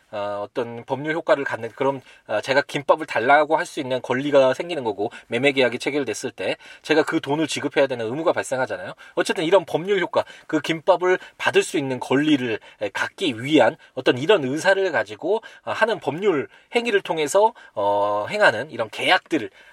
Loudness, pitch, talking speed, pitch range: -22 LUFS, 155 Hz, 360 characters per minute, 130-205 Hz